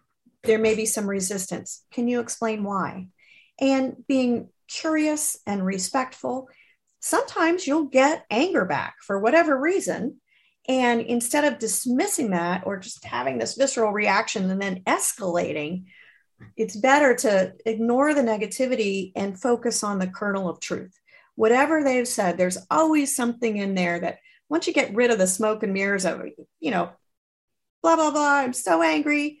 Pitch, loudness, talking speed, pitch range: 235 Hz, -23 LUFS, 155 wpm, 200-275 Hz